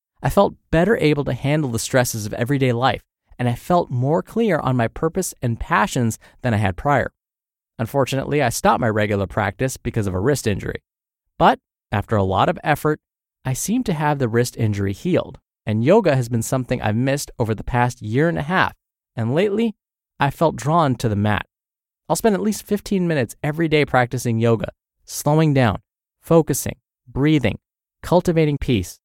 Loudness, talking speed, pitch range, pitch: -20 LUFS, 180 wpm, 115-155 Hz, 130 Hz